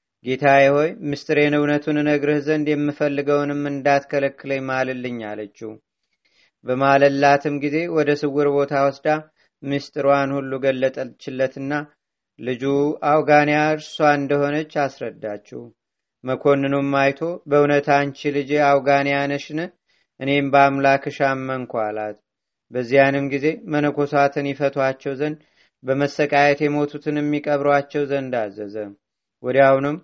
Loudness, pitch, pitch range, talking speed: -20 LUFS, 140 Hz, 135-145 Hz, 90 wpm